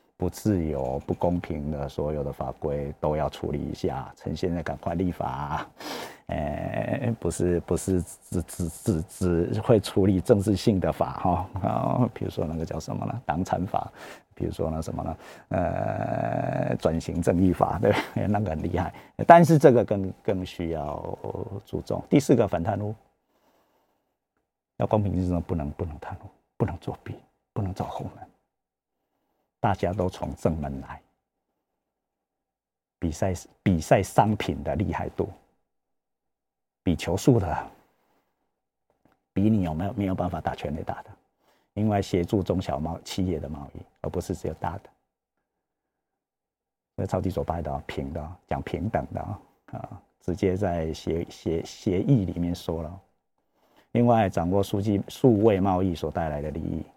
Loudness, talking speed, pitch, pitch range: -27 LUFS, 220 characters per minute, 90 Hz, 80-100 Hz